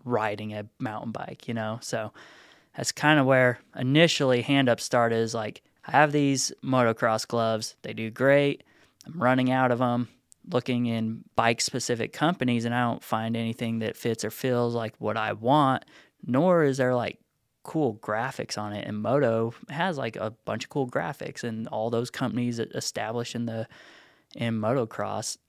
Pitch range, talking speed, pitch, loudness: 115-130 Hz, 175 wpm, 120 Hz, -26 LUFS